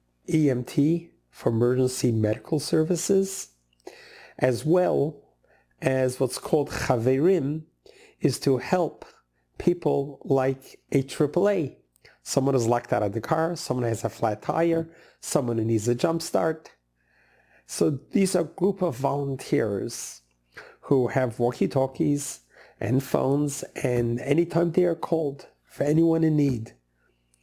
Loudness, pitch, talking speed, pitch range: -25 LUFS, 135 Hz, 125 wpm, 120-160 Hz